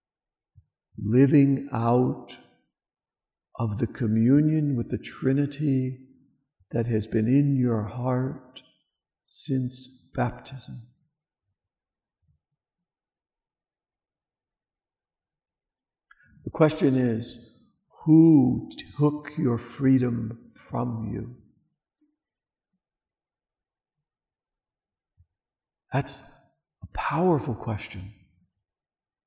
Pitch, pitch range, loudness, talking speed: 125 Hz, 110-140 Hz, -25 LUFS, 60 wpm